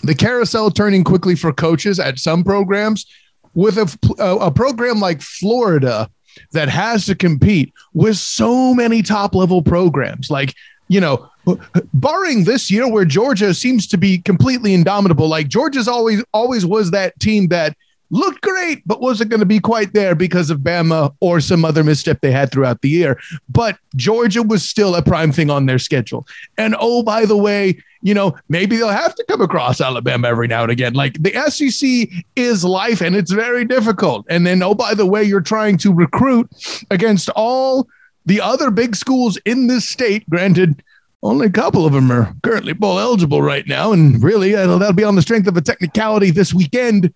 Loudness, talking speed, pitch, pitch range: -15 LUFS, 185 wpm, 195 Hz, 170-225 Hz